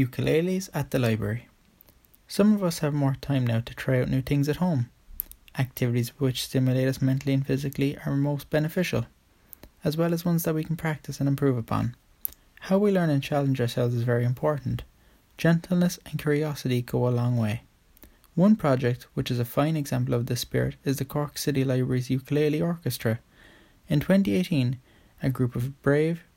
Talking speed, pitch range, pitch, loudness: 180 wpm, 125-150 Hz, 135 Hz, -26 LUFS